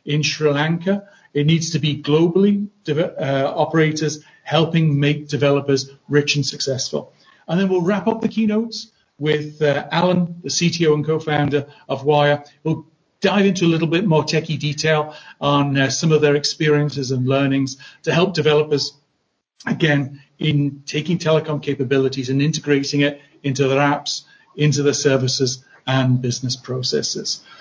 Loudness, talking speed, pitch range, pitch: -19 LUFS, 150 wpm, 140-160 Hz, 150 Hz